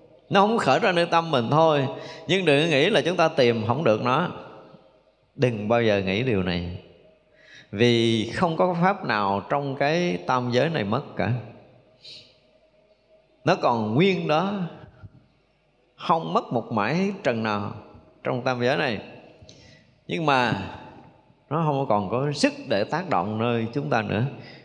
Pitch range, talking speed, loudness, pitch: 115-155 Hz, 155 wpm, -23 LUFS, 125 Hz